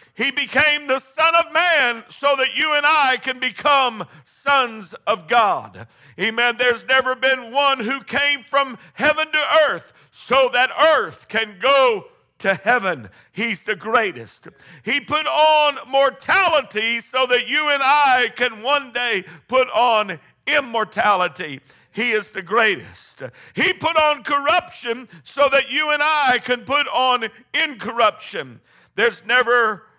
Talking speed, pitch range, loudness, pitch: 140 wpm, 225-290 Hz, -18 LUFS, 255 Hz